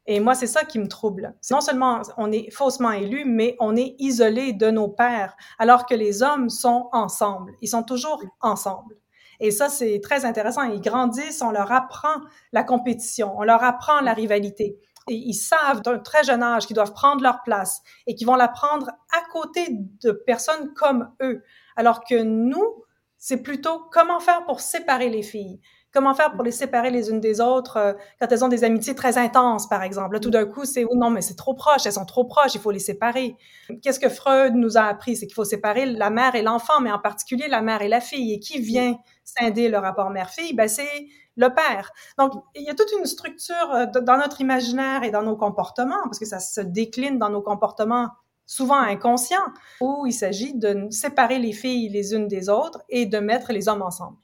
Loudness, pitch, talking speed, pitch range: -22 LUFS, 240 Hz, 210 wpm, 215-265 Hz